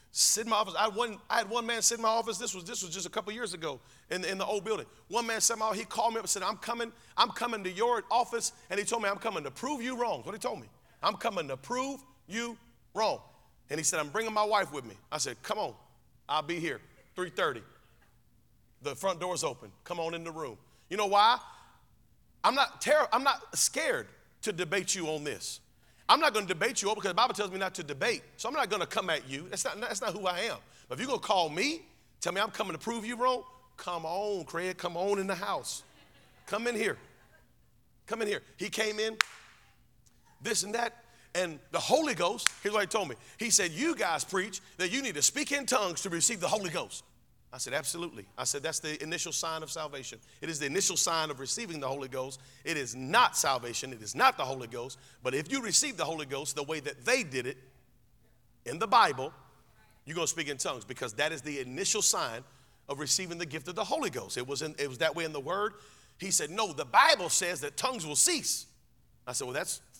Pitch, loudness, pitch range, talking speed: 190 Hz, -31 LUFS, 155-225 Hz, 250 wpm